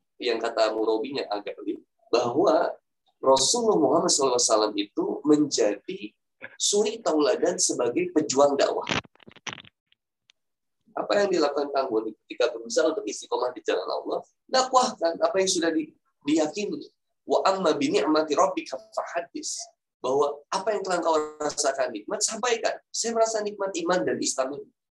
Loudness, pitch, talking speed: -25 LUFS, 180 Hz, 120 wpm